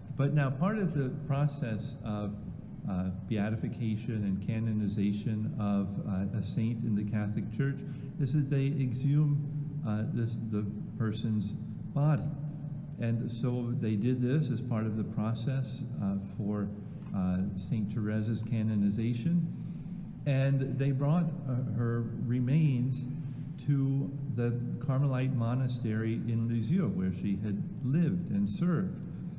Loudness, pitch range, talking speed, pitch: -32 LUFS, 110-145 Hz, 125 wpm, 125 Hz